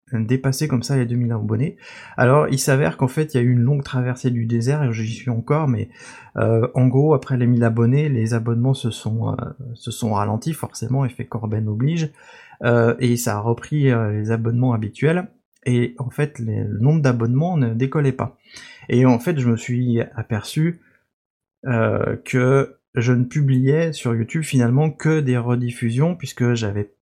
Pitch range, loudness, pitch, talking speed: 115-135 Hz, -20 LUFS, 125 Hz, 185 wpm